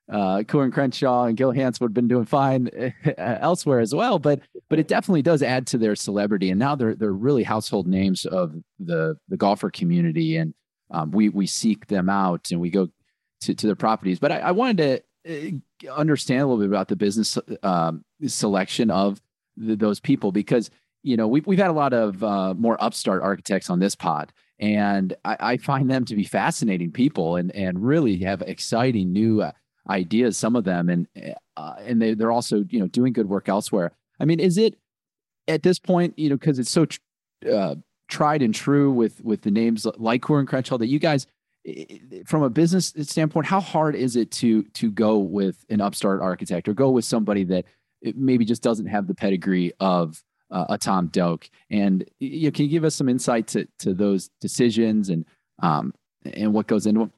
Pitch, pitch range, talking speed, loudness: 115 Hz, 100-145 Hz, 205 wpm, -22 LUFS